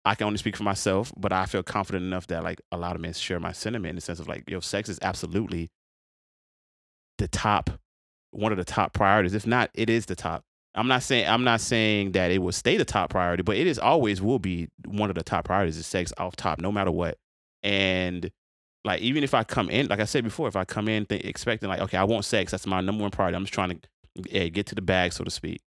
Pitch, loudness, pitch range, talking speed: 95 Hz, -26 LUFS, 90-105 Hz, 260 wpm